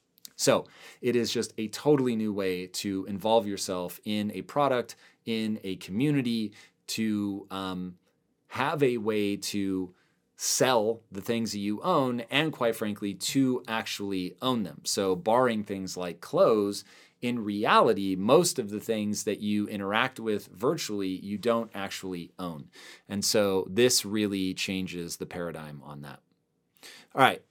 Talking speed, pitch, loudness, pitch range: 145 wpm, 105 Hz, -28 LUFS, 95-115 Hz